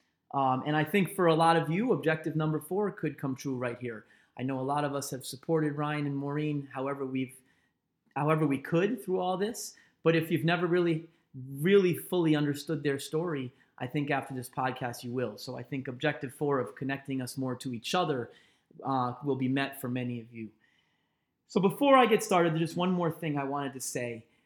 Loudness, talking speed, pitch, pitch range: -30 LUFS, 215 wpm, 145 Hz, 130-165 Hz